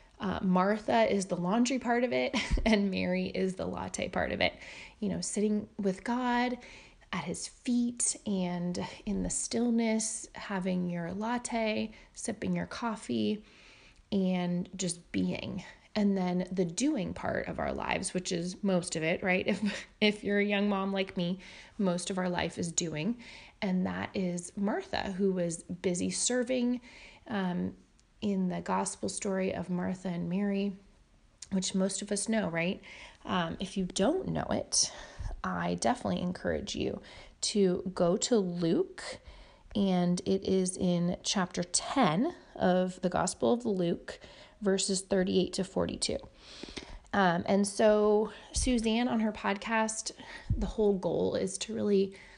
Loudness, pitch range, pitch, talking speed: -31 LUFS, 180-215 Hz, 195 Hz, 150 wpm